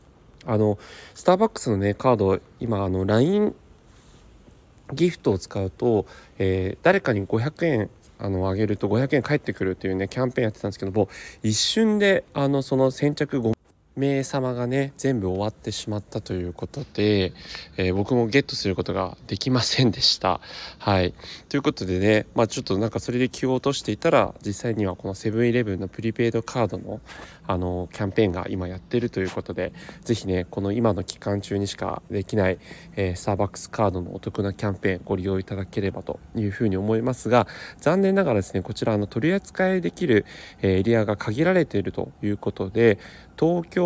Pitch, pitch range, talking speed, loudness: 110 Hz, 95-130 Hz, 400 characters per minute, -24 LUFS